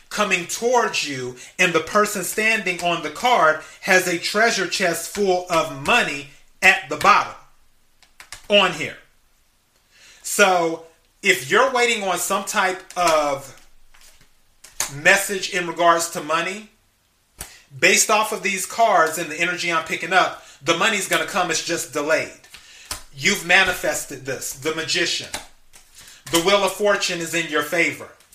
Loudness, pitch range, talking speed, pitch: -19 LUFS, 160-195 Hz, 140 wpm, 175 Hz